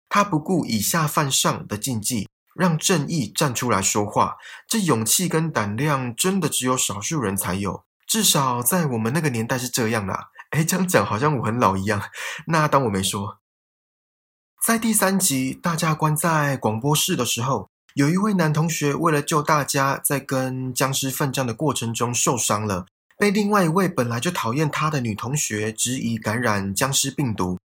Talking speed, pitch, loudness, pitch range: 265 characters per minute, 135 Hz, -21 LUFS, 110-160 Hz